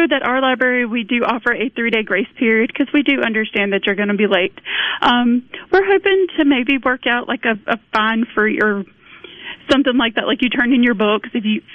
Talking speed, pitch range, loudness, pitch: 225 wpm, 220-270 Hz, -16 LUFS, 240 Hz